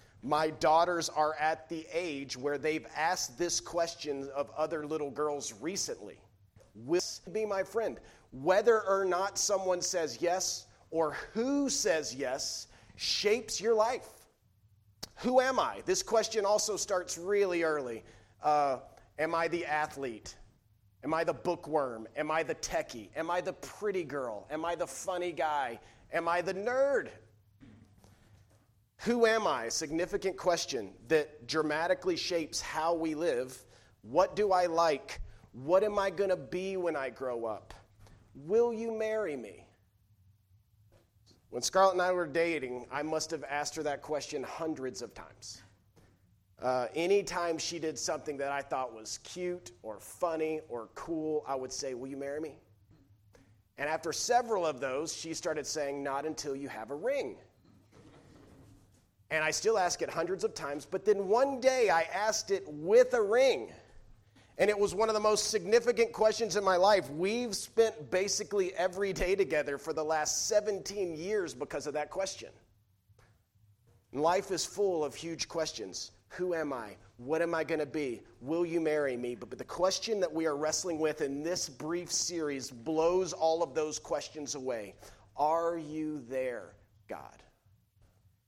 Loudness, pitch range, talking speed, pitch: -32 LUFS, 125-185 Hz, 160 wpm, 155 Hz